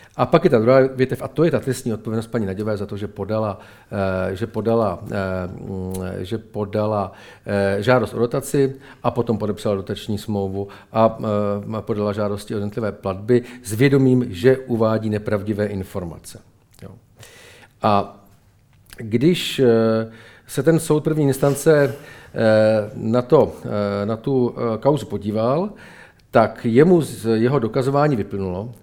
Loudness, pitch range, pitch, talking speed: -20 LUFS, 100-125 Hz, 110 Hz, 125 wpm